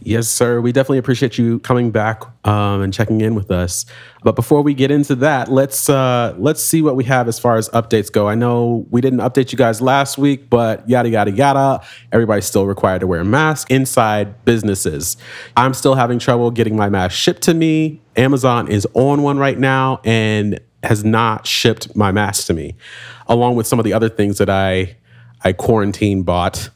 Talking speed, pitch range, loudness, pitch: 200 wpm, 105-130 Hz, -15 LUFS, 120 Hz